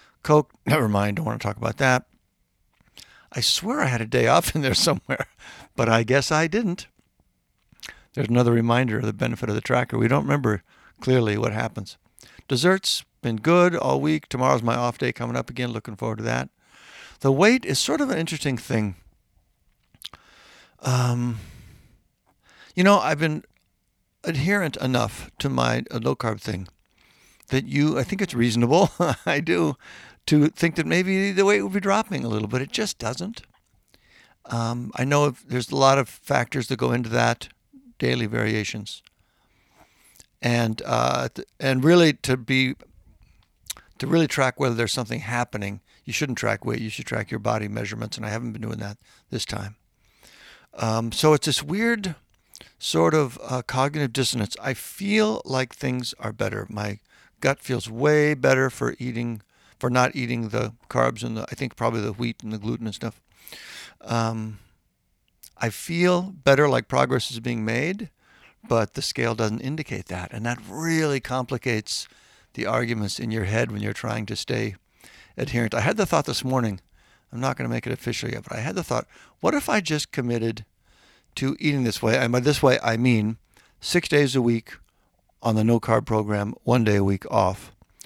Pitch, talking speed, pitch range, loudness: 120 Hz, 180 wpm, 110-140 Hz, -23 LUFS